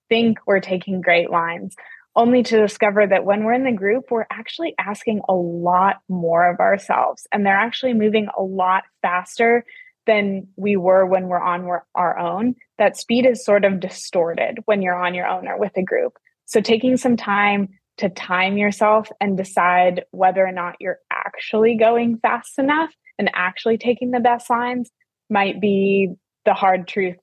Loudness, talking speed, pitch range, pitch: -19 LUFS, 175 wpm, 185-235 Hz, 205 Hz